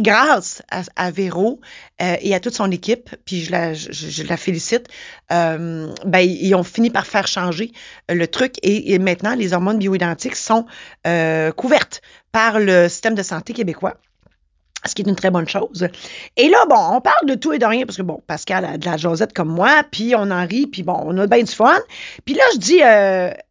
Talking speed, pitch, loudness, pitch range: 215 wpm, 190 Hz, -17 LUFS, 175-230 Hz